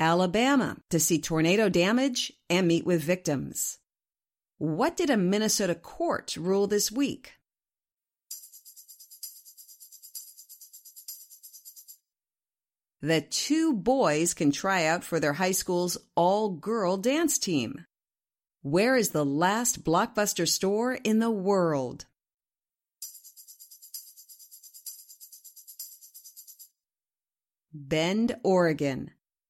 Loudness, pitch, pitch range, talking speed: -26 LUFS, 185 Hz, 165-225 Hz, 85 wpm